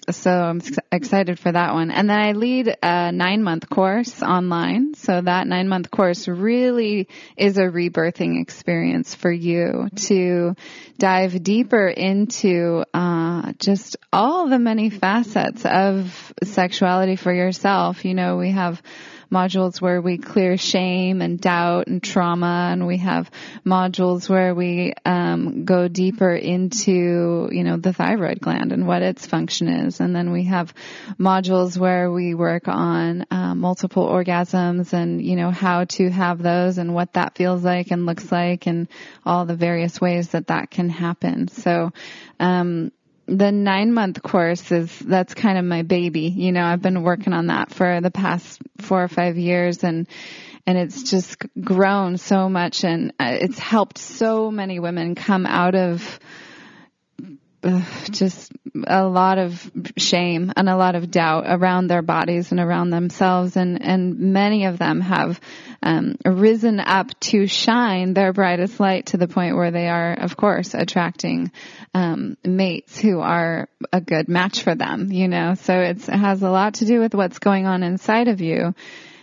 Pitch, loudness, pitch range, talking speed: 180 Hz, -20 LUFS, 175-195 Hz, 165 wpm